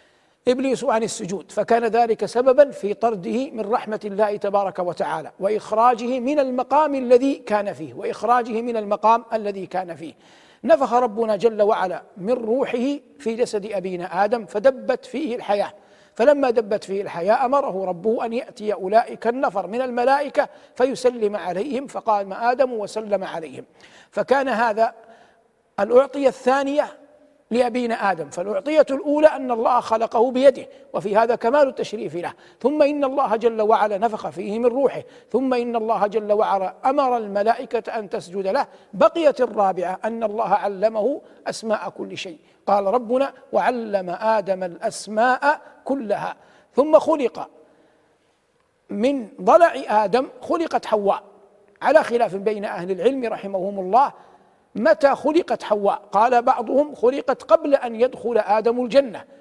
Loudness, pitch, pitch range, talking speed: -21 LUFS, 230 Hz, 205-265 Hz, 130 wpm